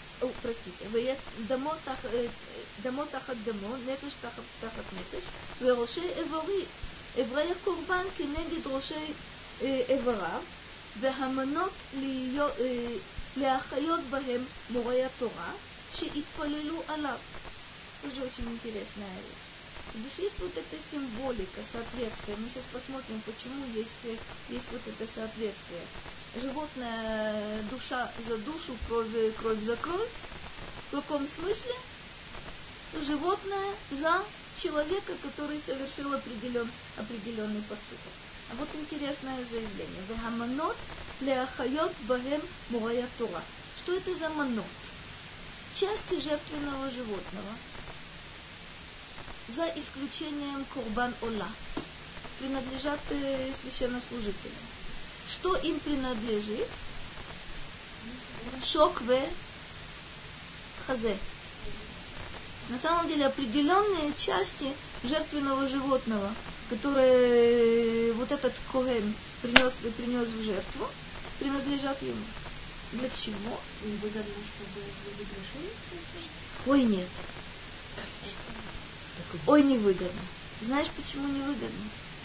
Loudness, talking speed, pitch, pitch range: -33 LUFS, 75 wpm, 260 Hz, 230-295 Hz